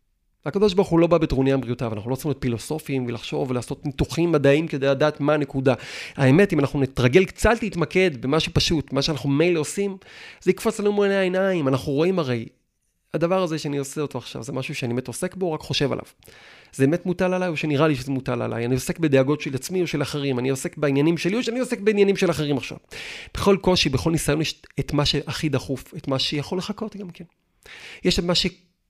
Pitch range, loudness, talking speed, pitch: 135-180 Hz, -22 LUFS, 190 wpm, 150 Hz